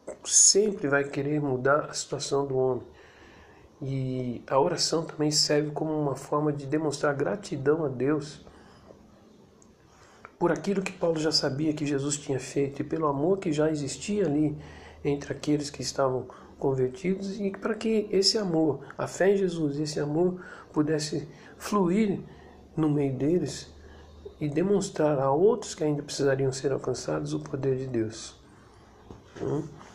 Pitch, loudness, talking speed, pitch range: 150 Hz, -27 LUFS, 145 wpm, 135-165 Hz